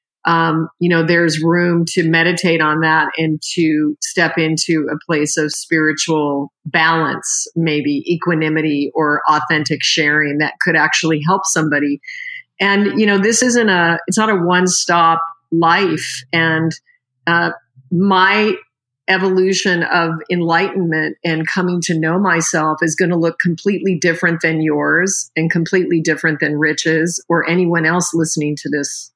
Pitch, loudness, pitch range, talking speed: 165 Hz, -15 LUFS, 155-180 Hz, 140 wpm